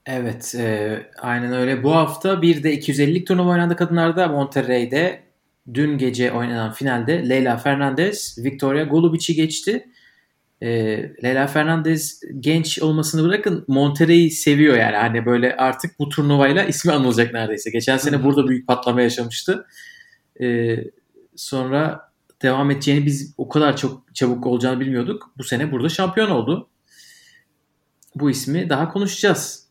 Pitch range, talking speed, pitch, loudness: 125-165 Hz, 130 wpm, 145 Hz, -19 LUFS